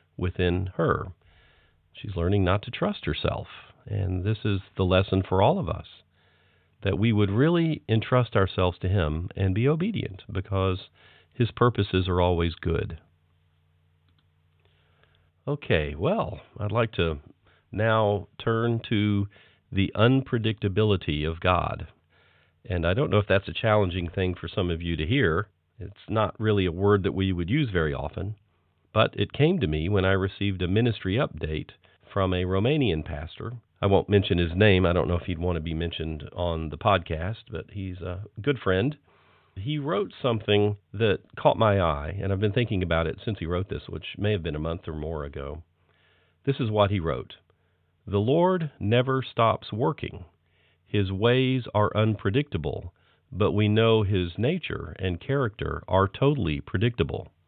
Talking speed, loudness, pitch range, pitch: 165 wpm, -26 LUFS, 85-110 Hz, 95 Hz